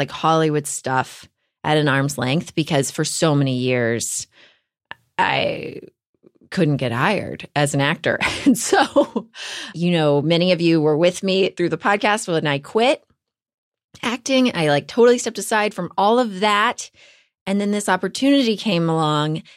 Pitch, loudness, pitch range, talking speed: 170 Hz, -19 LUFS, 145-210 Hz, 155 wpm